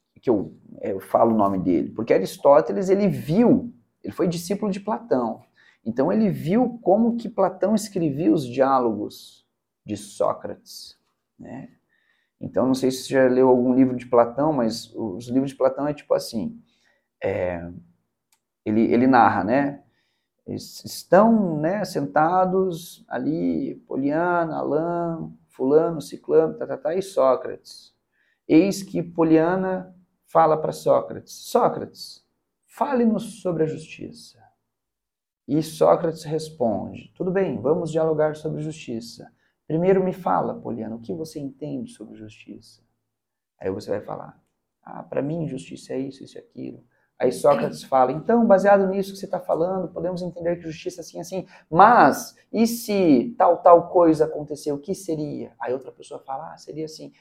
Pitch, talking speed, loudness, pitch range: 160 Hz, 150 wpm, -22 LUFS, 130-190 Hz